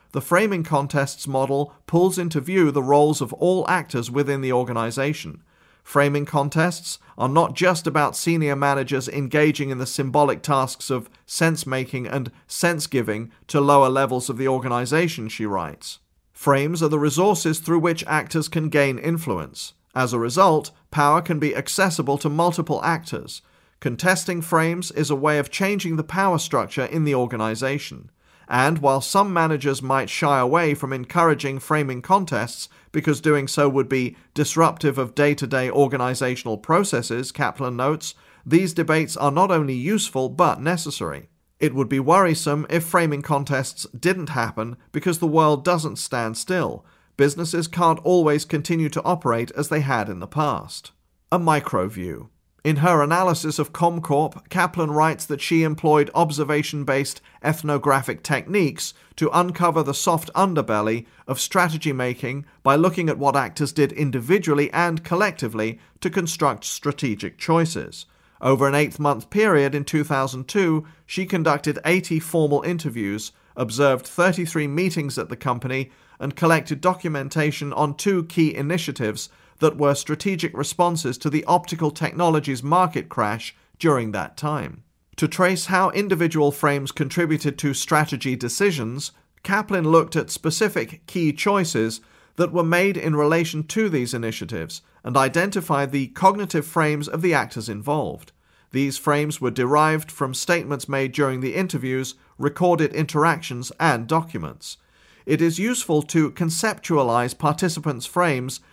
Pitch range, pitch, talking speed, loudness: 135-165 Hz, 150 Hz, 145 wpm, -21 LUFS